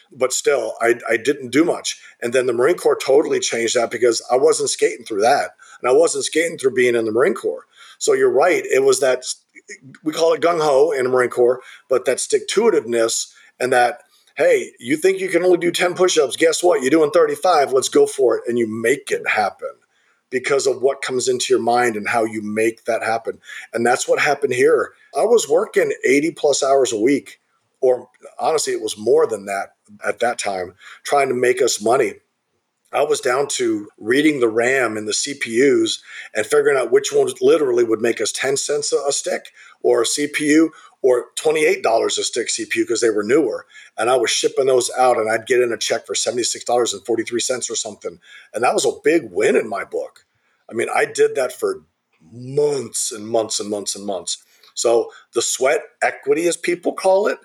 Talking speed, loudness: 210 wpm, -18 LUFS